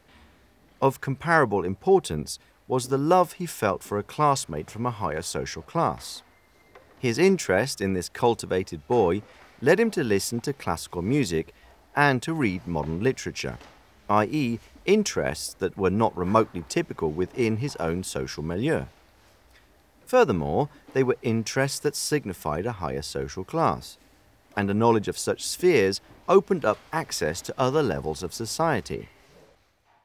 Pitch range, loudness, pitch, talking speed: 90-140 Hz, -25 LUFS, 110 Hz, 140 wpm